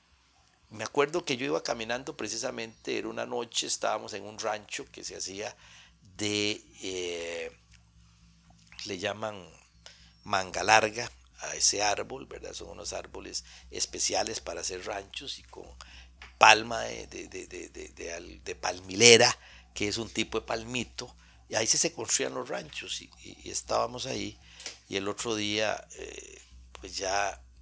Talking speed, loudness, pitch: 150 wpm, -28 LUFS, 105 Hz